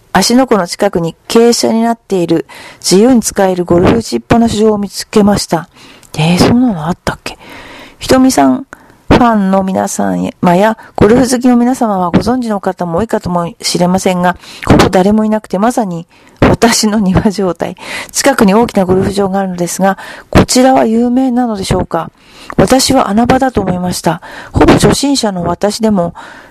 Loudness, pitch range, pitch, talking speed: -10 LUFS, 180-230 Hz, 200 Hz, 345 characters per minute